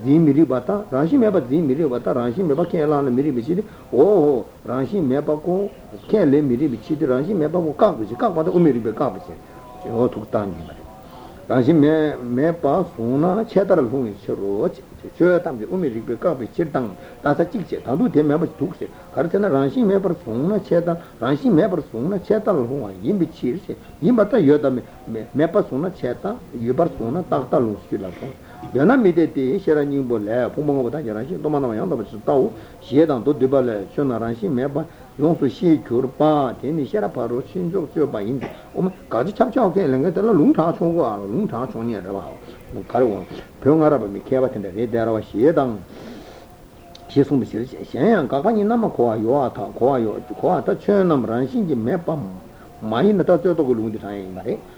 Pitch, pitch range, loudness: 145 Hz, 120-170 Hz, -20 LUFS